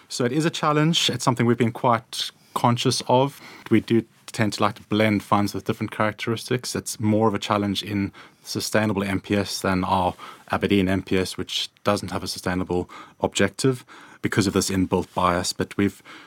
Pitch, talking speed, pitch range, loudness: 105 Hz, 175 wpm, 95-115 Hz, -23 LUFS